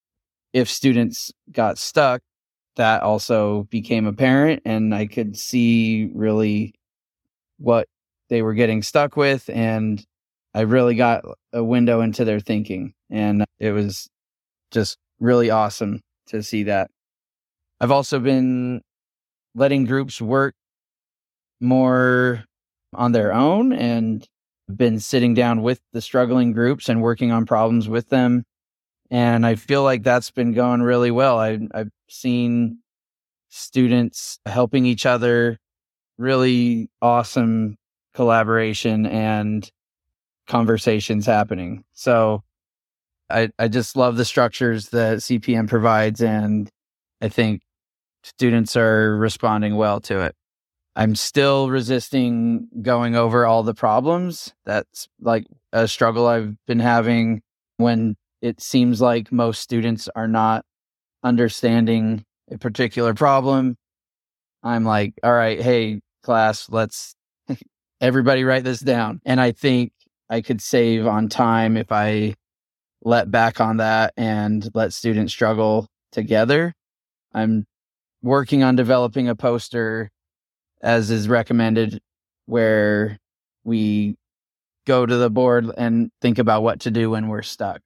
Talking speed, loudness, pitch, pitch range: 125 wpm, -19 LUFS, 115 Hz, 110-125 Hz